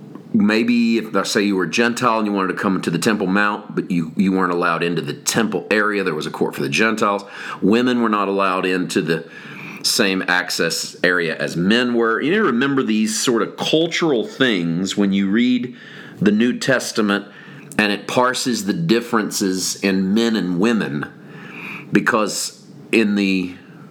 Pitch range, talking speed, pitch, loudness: 95-115 Hz, 180 wpm, 105 Hz, -18 LUFS